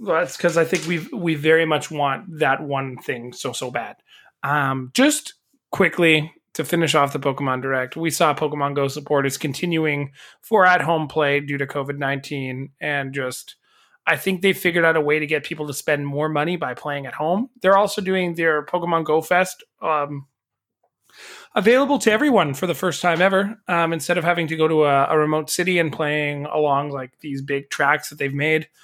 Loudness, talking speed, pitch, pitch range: -20 LUFS, 200 wpm, 155 Hz, 140-175 Hz